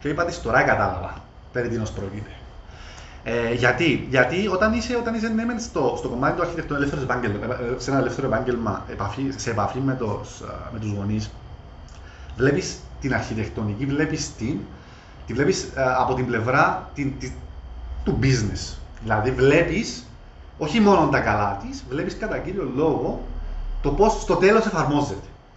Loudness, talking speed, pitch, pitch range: -23 LUFS, 160 wpm, 125 Hz, 100-140 Hz